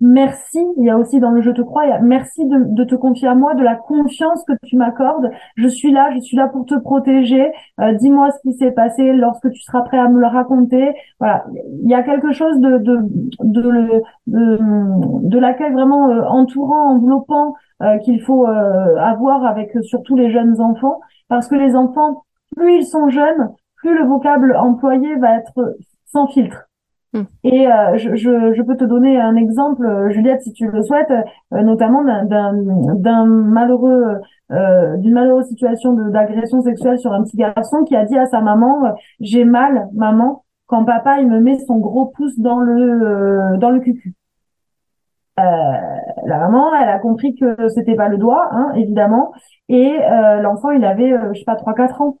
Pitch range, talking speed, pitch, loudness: 225-270 Hz, 195 wpm, 245 Hz, -14 LUFS